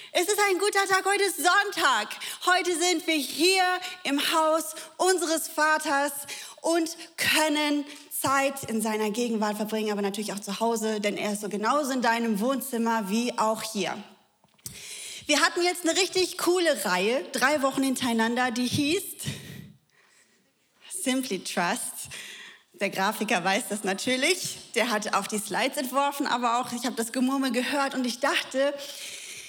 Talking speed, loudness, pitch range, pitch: 150 wpm, -26 LUFS, 225-325 Hz, 275 Hz